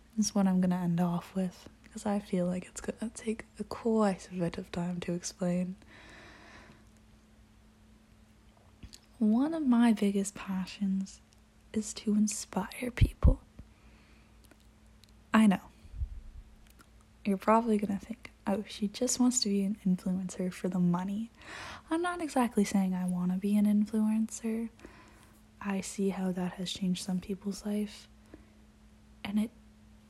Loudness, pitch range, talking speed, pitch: -32 LUFS, 170-215 Hz, 140 wpm, 190 Hz